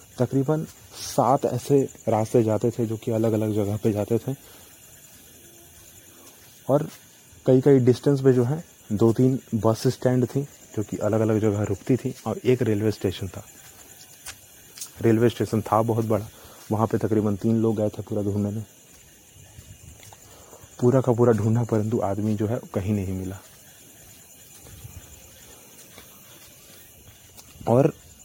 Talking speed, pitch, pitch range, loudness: 140 wpm, 110 Hz, 100-120 Hz, -23 LUFS